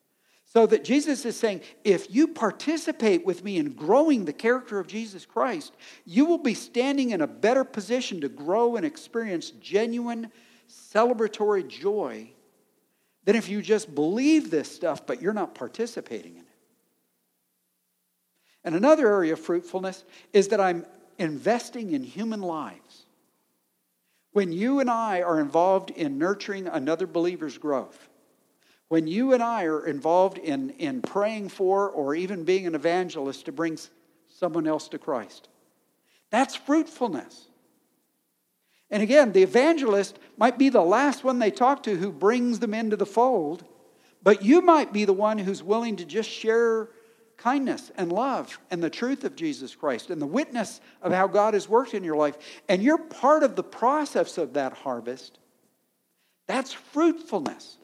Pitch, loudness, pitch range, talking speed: 220 Hz, -25 LUFS, 180-260 Hz, 155 wpm